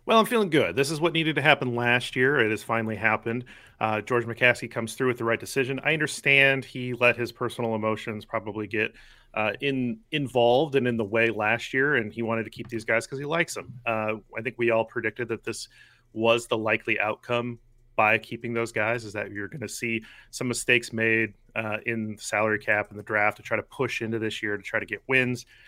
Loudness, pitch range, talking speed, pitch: -25 LUFS, 110-125 Hz, 230 wpm, 115 Hz